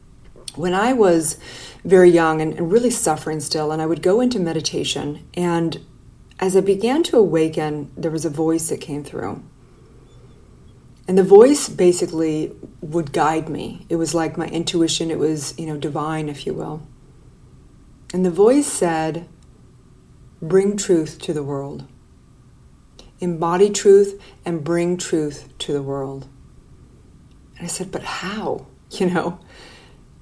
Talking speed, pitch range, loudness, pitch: 145 wpm, 150-180 Hz, -19 LUFS, 165 Hz